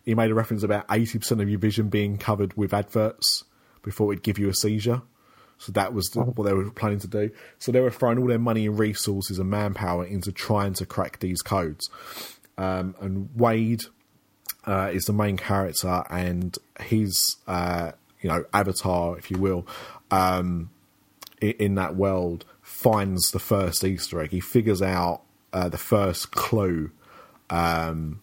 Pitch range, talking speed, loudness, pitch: 90-110 Hz, 170 wpm, -25 LUFS, 100 Hz